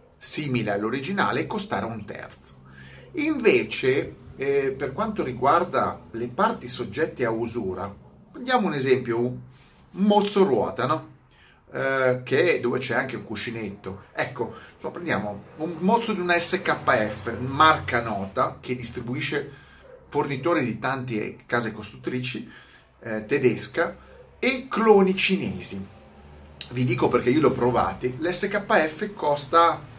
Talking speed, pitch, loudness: 120 wpm, 130 Hz, -24 LUFS